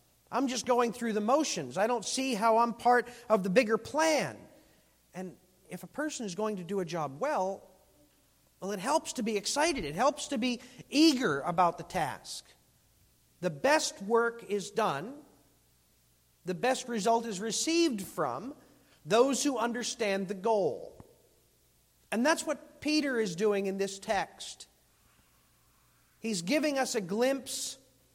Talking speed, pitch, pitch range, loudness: 150 wpm, 230 Hz, 190-265 Hz, -30 LUFS